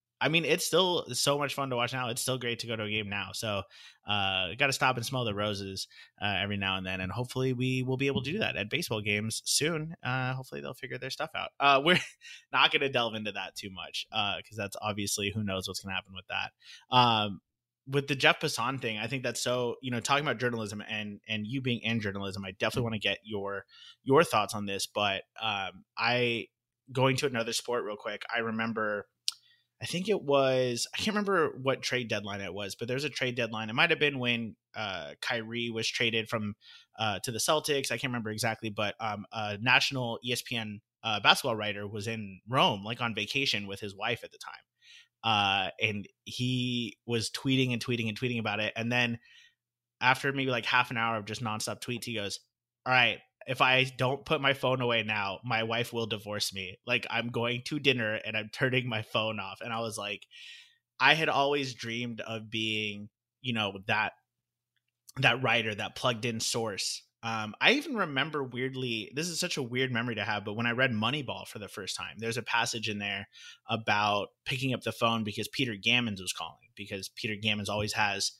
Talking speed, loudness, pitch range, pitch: 215 wpm, -30 LUFS, 105-130 Hz, 115 Hz